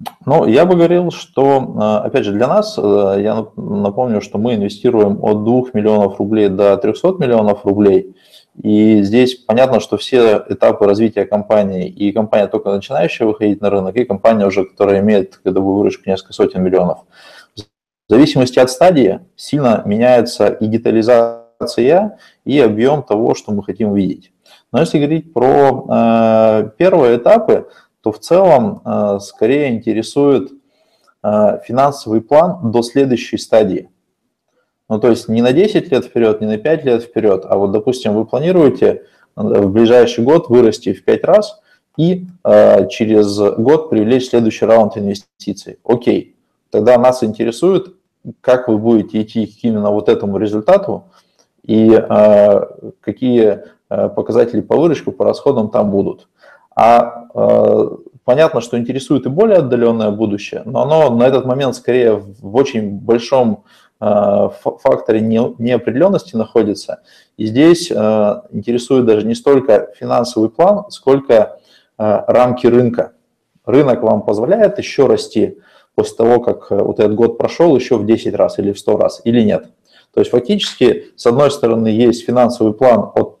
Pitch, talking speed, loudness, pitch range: 115 Hz, 145 wpm, -13 LUFS, 105-125 Hz